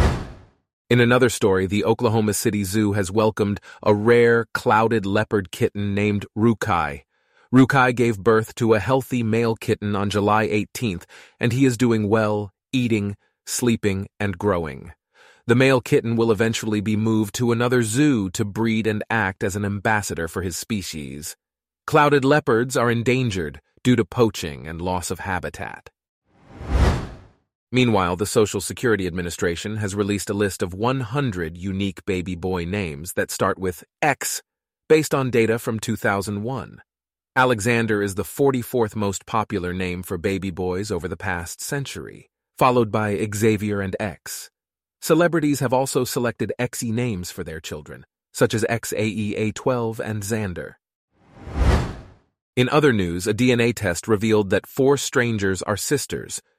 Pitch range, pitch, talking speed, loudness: 100-120 Hz, 110 Hz, 145 wpm, -21 LUFS